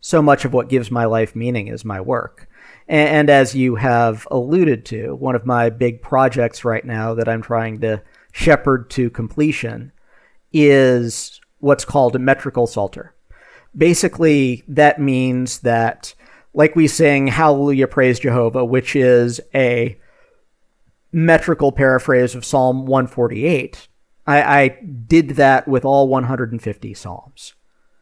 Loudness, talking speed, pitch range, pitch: -16 LUFS, 135 wpm, 120-145 Hz, 130 Hz